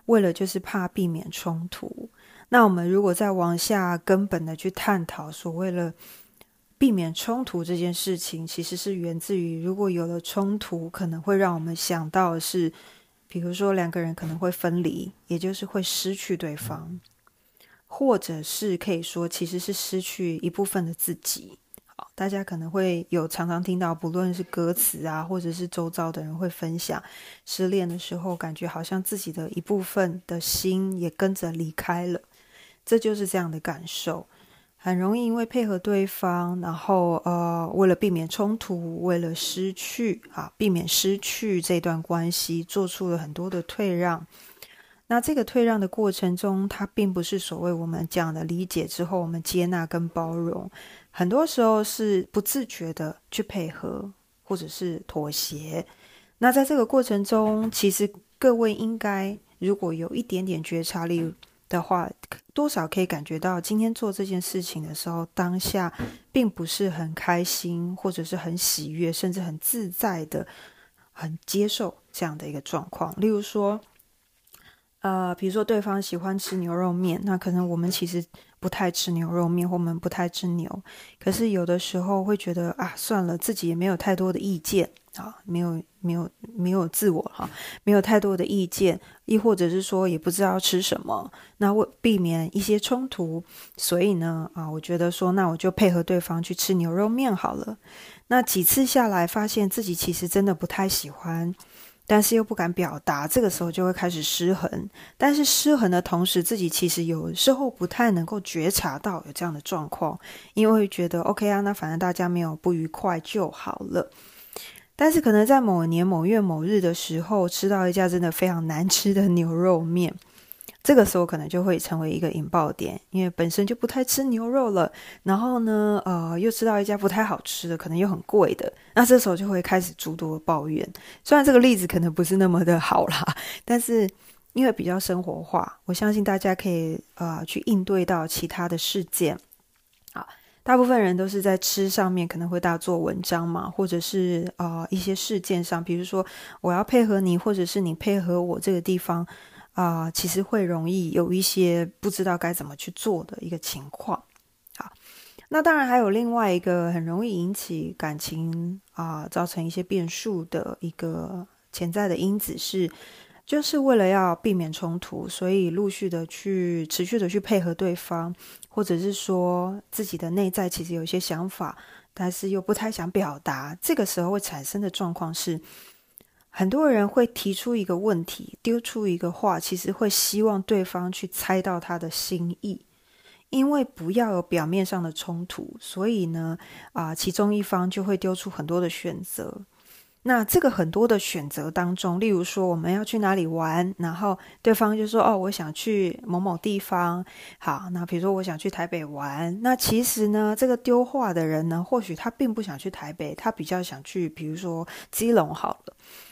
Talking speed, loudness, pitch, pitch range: 270 characters per minute, -25 LUFS, 185 Hz, 170-200 Hz